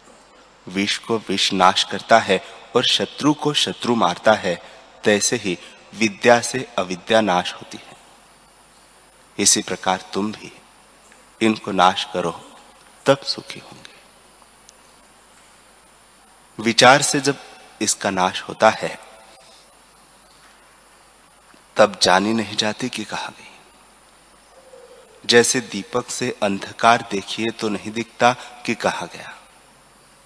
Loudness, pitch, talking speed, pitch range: -19 LUFS, 110 Hz, 110 wpm, 100-120 Hz